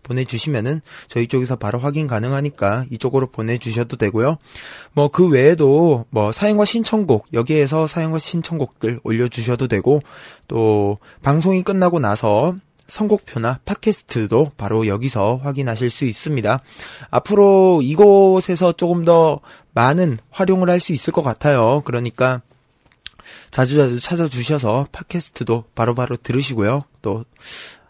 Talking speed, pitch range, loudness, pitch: 315 characters per minute, 120-165 Hz, -17 LUFS, 135 Hz